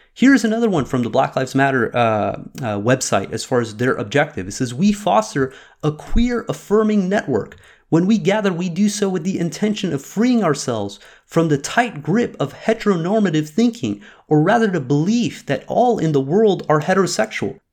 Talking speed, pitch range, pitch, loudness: 185 wpm, 130-215 Hz, 165 Hz, -18 LUFS